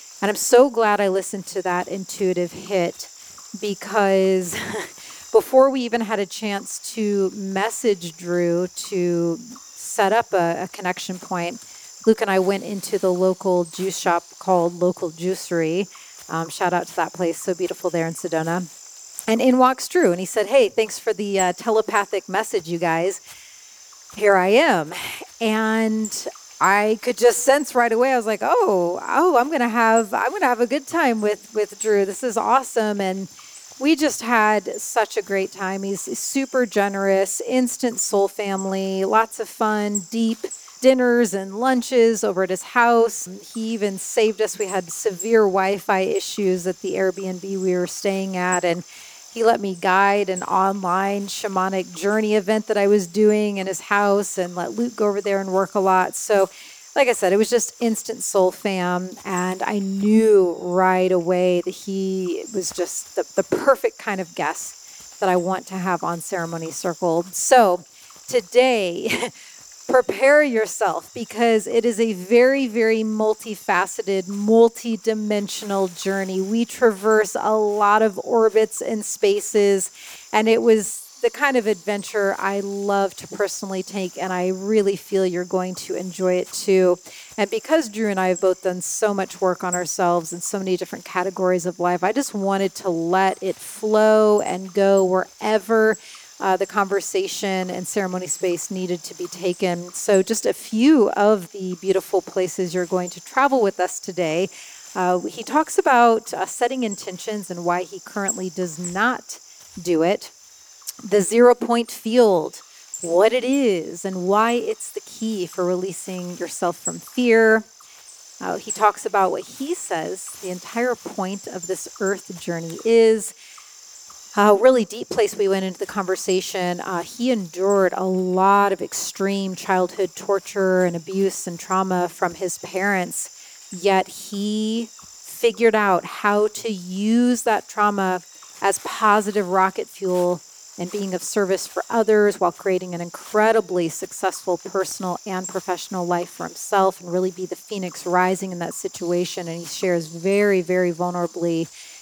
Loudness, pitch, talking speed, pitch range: -21 LUFS, 195 Hz, 165 wpm, 185-220 Hz